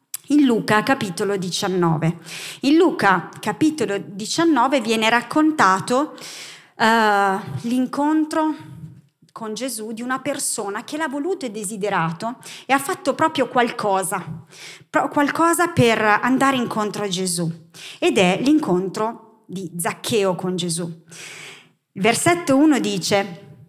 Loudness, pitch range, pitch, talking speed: -20 LUFS, 185-270 Hz, 215 Hz, 110 wpm